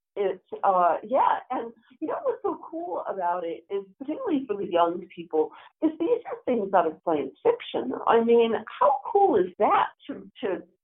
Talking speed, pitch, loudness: 185 wpm, 235 Hz, -26 LUFS